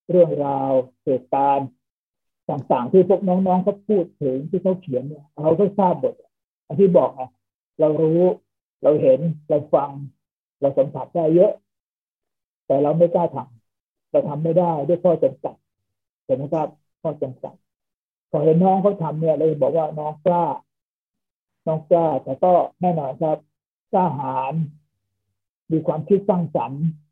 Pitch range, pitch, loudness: 135-175 Hz, 155 Hz, -20 LUFS